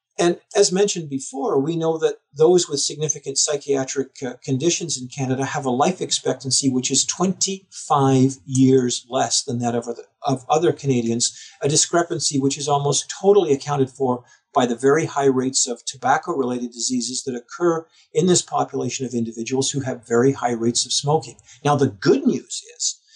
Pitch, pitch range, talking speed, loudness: 135 Hz, 125-160 Hz, 165 wpm, -20 LUFS